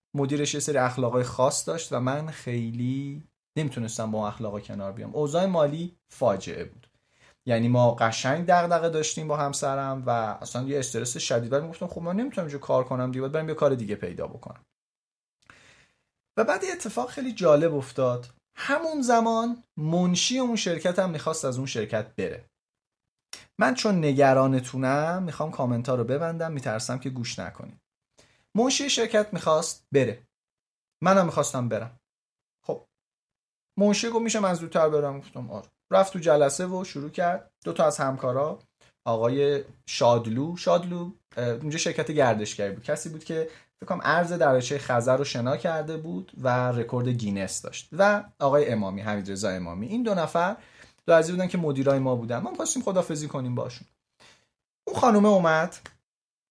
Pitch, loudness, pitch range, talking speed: 145 Hz, -26 LUFS, 125-175 Hz, 155 wpm